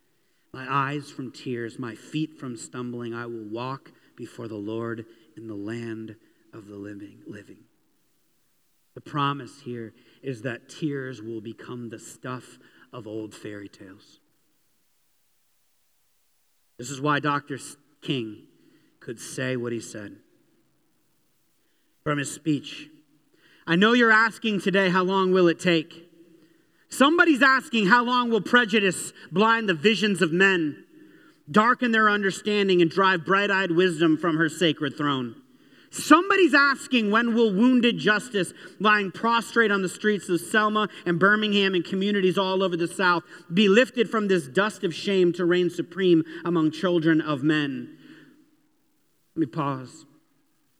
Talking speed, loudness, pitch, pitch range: 140 wpm, -23 LUFS, 175 Hz, 135-215 Hz